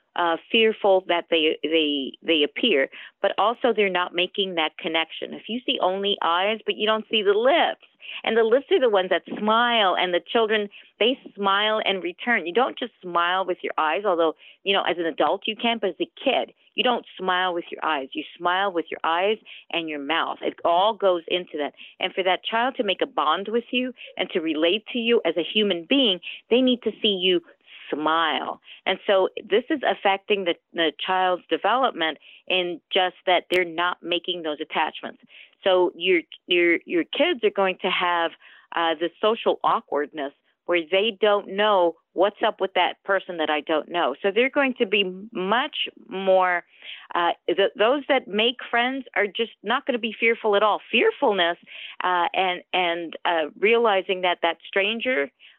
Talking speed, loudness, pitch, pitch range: 190 wpm, -23 LUFS, 195 Hz, 175-230 Hz